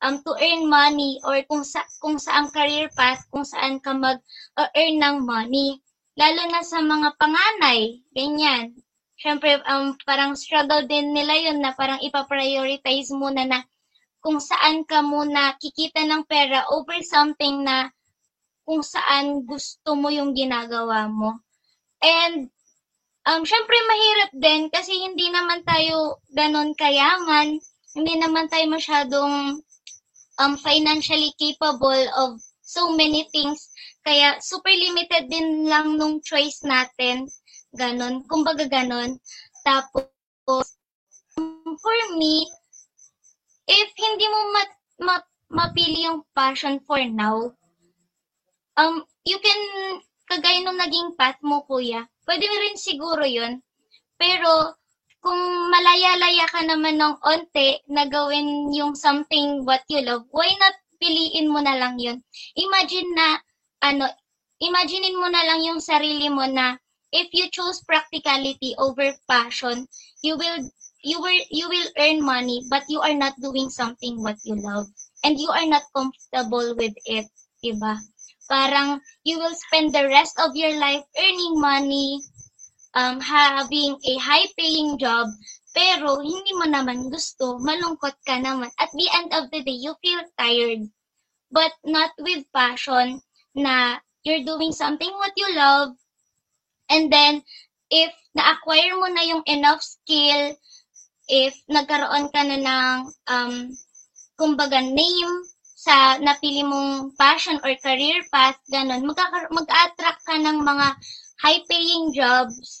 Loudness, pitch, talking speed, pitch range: -20 LUFS, 295 Hz, 135 wpm, 270-325 Hz